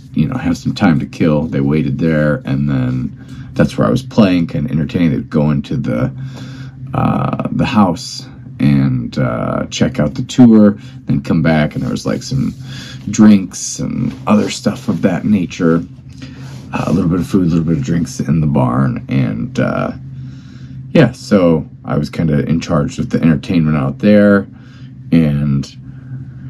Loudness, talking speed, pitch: -14 LUFS, 180 wpm, 105 Hz